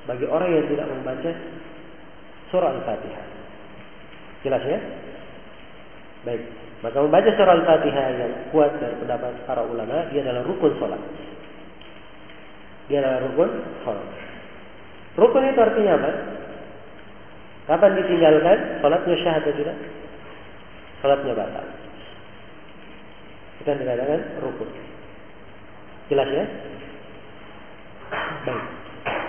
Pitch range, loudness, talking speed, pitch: 130-170 Hz, -22 LUFS, 95 wpm, 155 Hz